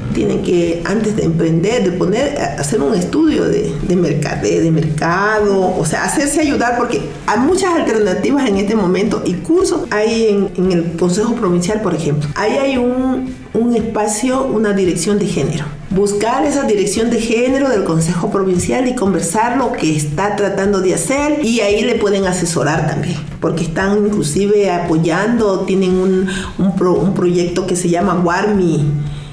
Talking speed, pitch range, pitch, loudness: 165 wpm, 175-220 Hz, 195 Hz, -15 LUFS